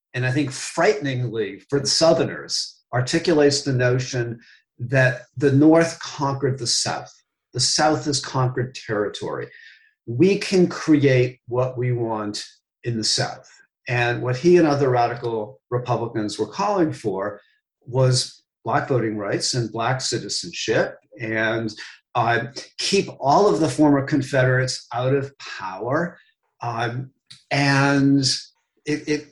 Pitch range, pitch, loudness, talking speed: 120-145 Hz, 130 Hz, -21 LUFS, 125 wpm